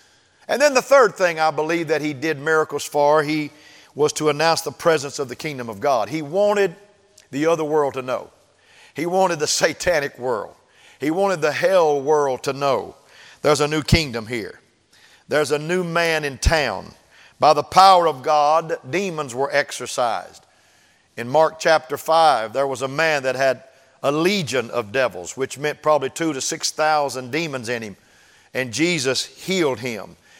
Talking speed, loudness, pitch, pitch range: 175 wpm, -20 LUFS, 155 Hz, 140-165 Hz